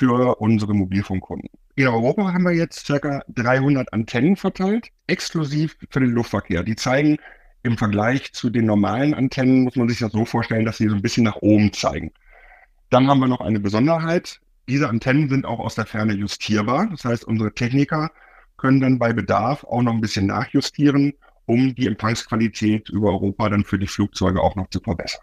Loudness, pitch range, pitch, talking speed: -20 LUFS, 105-140 Hz, 120 Hz, 185 wpm